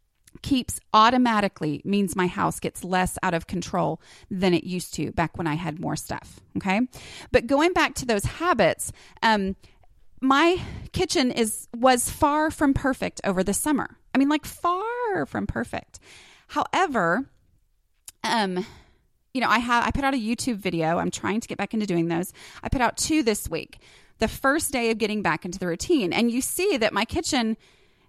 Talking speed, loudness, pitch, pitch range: 180 wpm, -24 LUFS, 230 Hz, 190-275 Hz